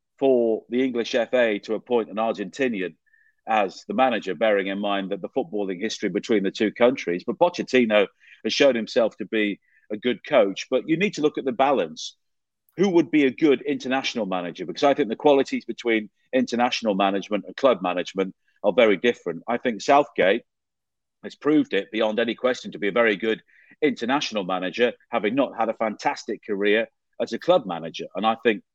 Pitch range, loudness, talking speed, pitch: 105-130 Hz, -23 LUFS, 190 wpm, 115 Hz